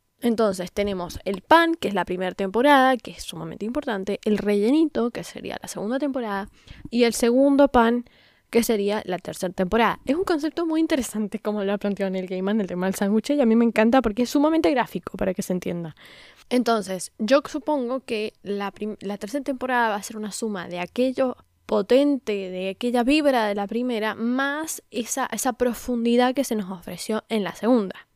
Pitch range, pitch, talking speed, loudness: 200-260 Hz, 225 Hz, 195 wpm, -23 LUFS